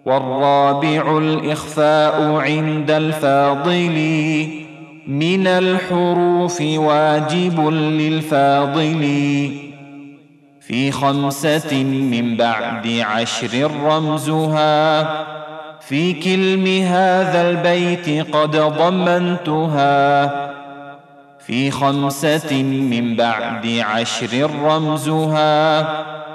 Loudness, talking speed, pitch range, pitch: -17 LUFS, 60 wpm, 140-155 Hz, 155 Hz